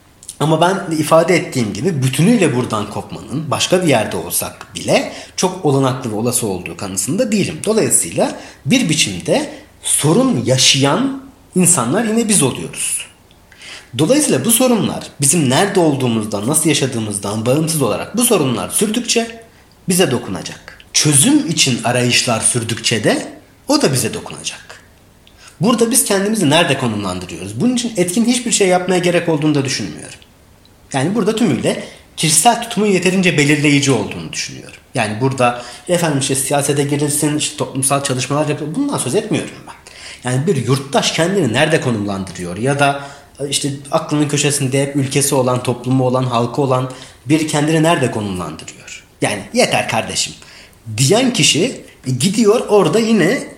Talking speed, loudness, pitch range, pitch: 135 wpm, -15 LUFS, 120-175 Hz, 140 Hz